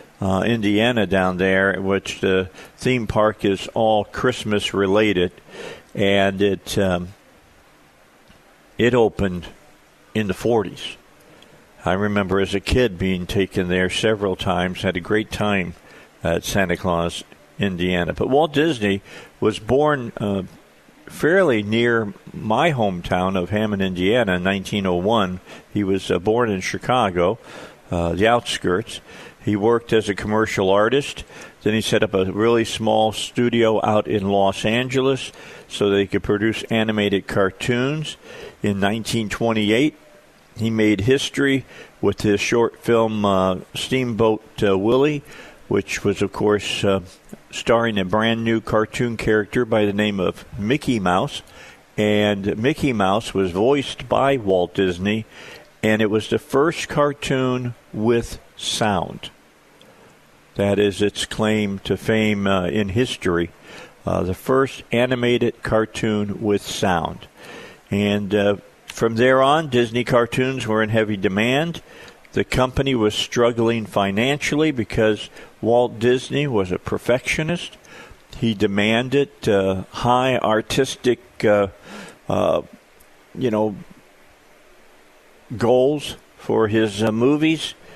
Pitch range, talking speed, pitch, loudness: 100-120 Hz, 125 wpm, 110 Hz, -20 LUFS